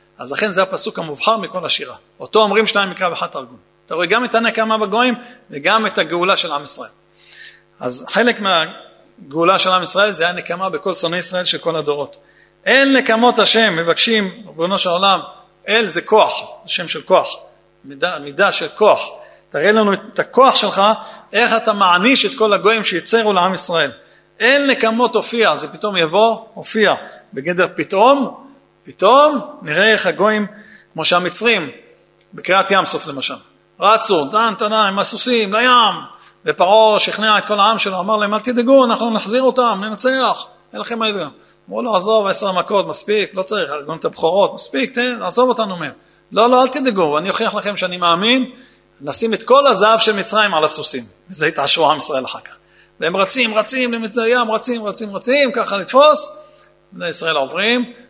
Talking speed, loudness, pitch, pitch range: 165 wpm, -15 LUFS, 215 Hz, 185-230 Hz